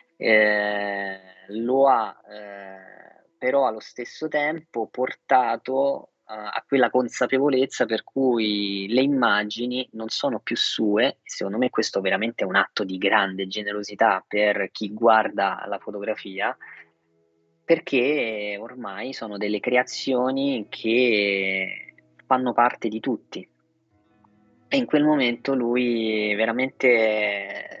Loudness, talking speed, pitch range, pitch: -23 LUFS, 115 wpm, 105-130 Hz, 110 Hz